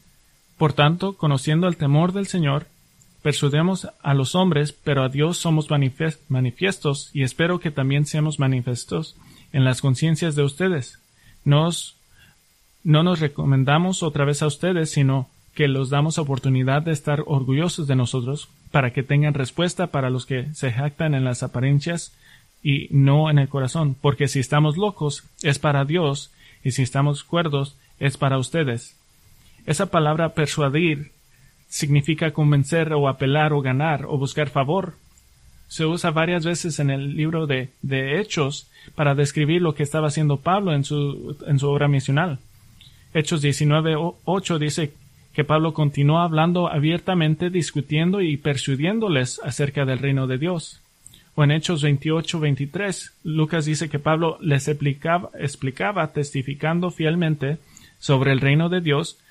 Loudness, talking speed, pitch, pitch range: -22 LUFS, 145 wpm, 150 Hz, 140-160 Hz